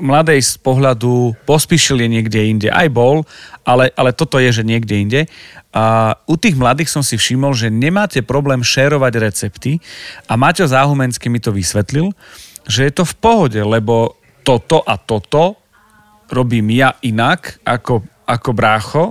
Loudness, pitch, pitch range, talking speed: -14 LUFS, 130 Hz, 115-150 Hz, 155 wpm